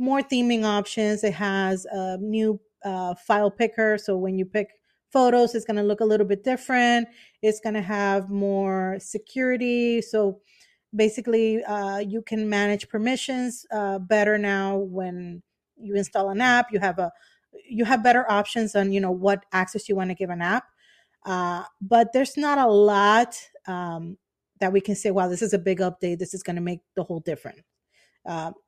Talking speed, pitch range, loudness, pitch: 185 wpm, 190-225 Hz, -24 LUFS, 205 Hz